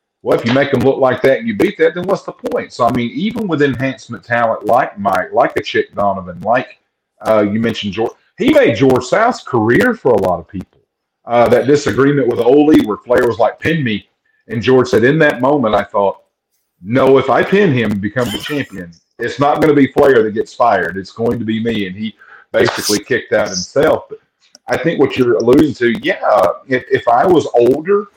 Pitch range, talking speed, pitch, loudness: 115-155 Hz, 225 wpm, 130 Hz, -14 LUFS